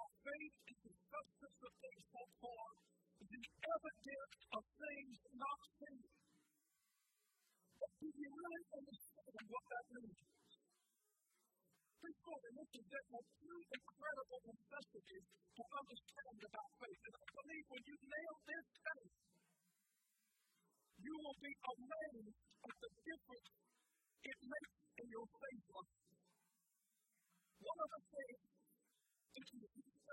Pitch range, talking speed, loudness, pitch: 225-300 Hz, 125 wpm, -55 LUFS, 265 Hz